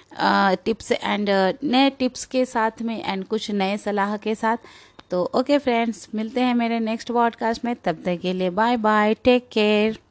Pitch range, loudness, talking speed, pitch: 205-240 Hz, -22 LUFS, 180 wpm, 225 Hz